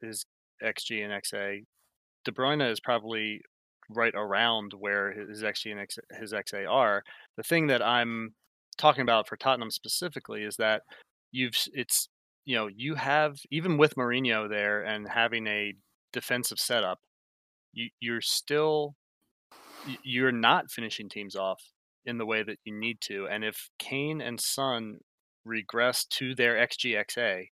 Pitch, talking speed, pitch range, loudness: 115 Hz, 150 wpm, 105-130 Hz, -29 LUFS